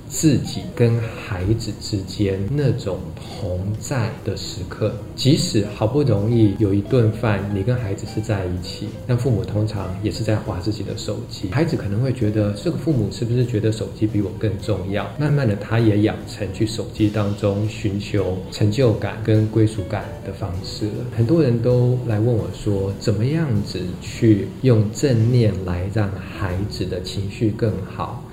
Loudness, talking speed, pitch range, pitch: -21 LUFS, 250 characters per minute, 100-115 Hz, 105 Hz